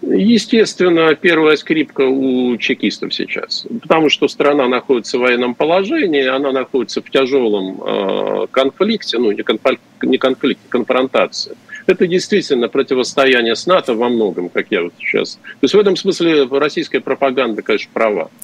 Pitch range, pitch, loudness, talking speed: 130-185 Hz, 140 Hz, -15 LUFS, 145 wpm